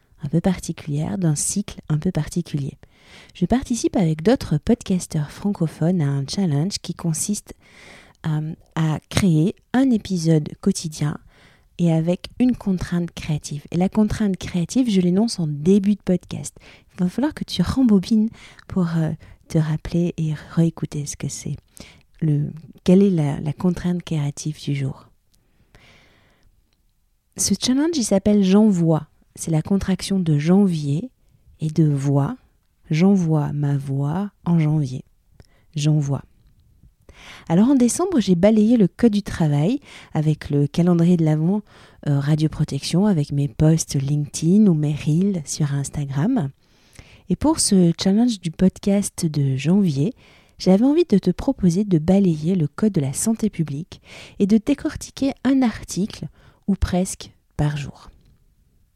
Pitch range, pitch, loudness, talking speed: 150-200 Hz, 170 Hz, -20 LUFS, 140 wpm